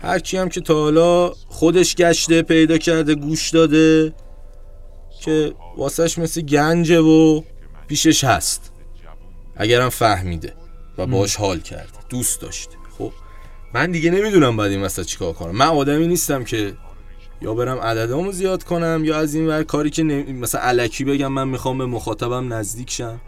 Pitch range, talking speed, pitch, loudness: 100-160 Hz, 155 wpm, 135 Hz, -18 LUFS